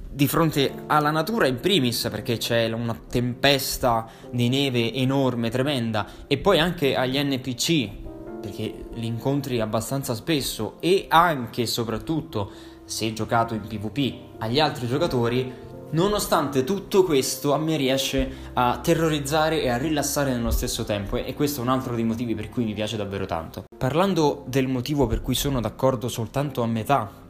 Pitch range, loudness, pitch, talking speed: 115-140 Hz, -24 LUFS, 130 Hz, 160 wpm